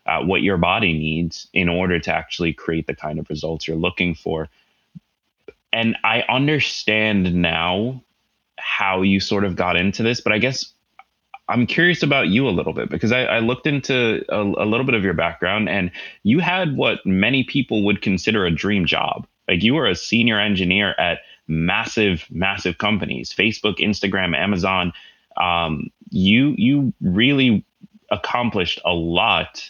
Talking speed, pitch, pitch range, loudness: 165 wpm, 100 Hz, 85-115 Hz, -19 LUFS